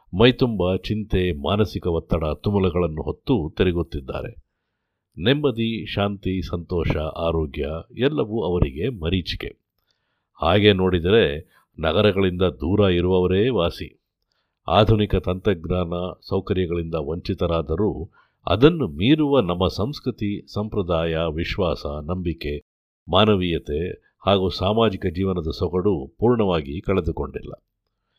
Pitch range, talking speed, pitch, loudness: 85-105 Hz, 80 wpm, 95 Hz, -22 LUFS